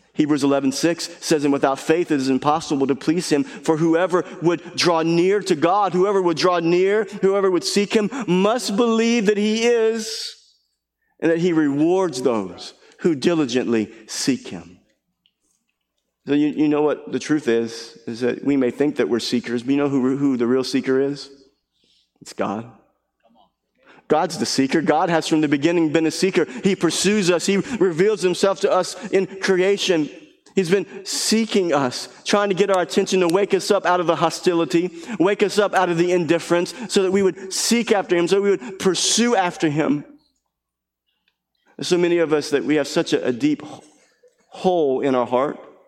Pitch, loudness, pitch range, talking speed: 170 Hz, -20 LUFS, 145-195 Hz, 185 wpm